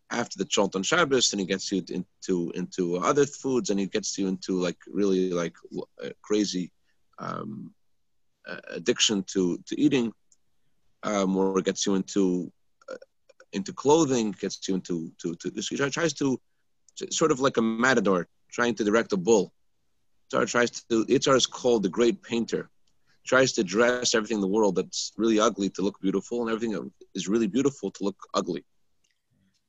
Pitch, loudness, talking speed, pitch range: 105 Hz, -26 LUFS, 180 wpm, 95-120 Hz